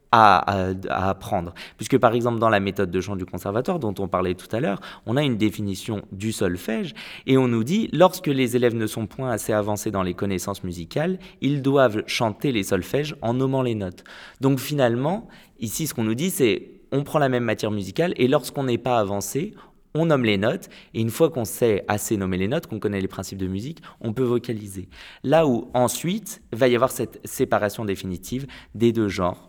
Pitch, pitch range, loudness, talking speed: 115 Hz, 100-135 Hz, -23 LUFS, 210 wpm